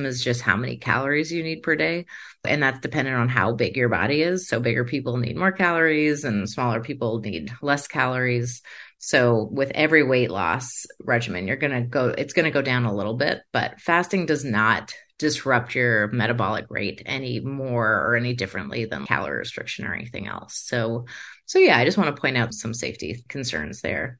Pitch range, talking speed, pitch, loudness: 115-145 Hz, 200 wpm, 125 Hz, -23 LUFS